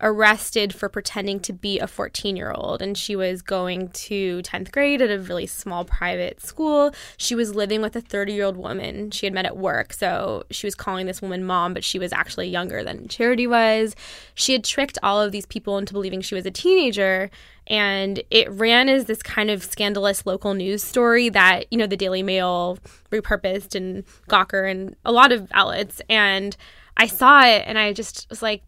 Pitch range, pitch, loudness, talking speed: 190-225 Hz, 205 Hz, -20 LUFS, 205 wpm